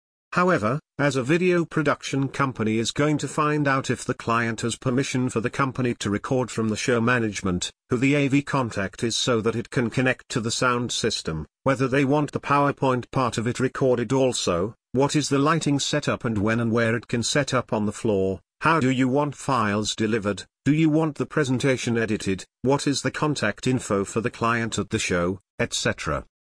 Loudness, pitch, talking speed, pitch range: -24 LUFS, 125 Hz, 200 wpm, 110-140 Hz